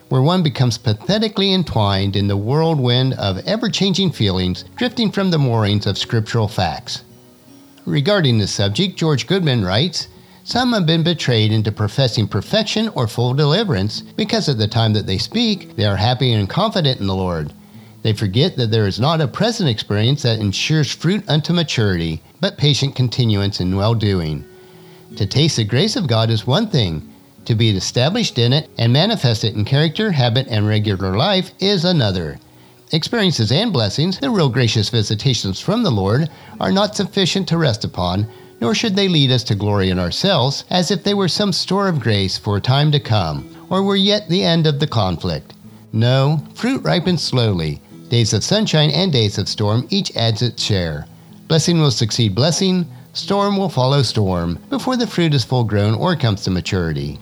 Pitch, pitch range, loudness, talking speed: 125 Hz, 105-175 Hz, -17 LUFS, 180 wpm